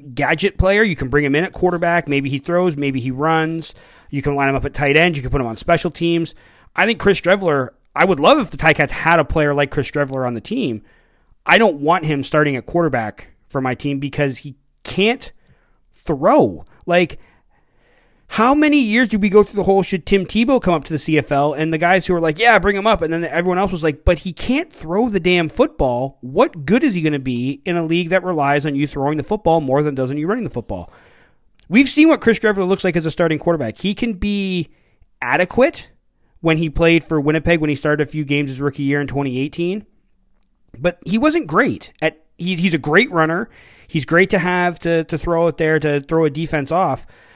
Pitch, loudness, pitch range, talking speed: 165 Hz, -17 LUFS, 145-185 Hz, 230 wpm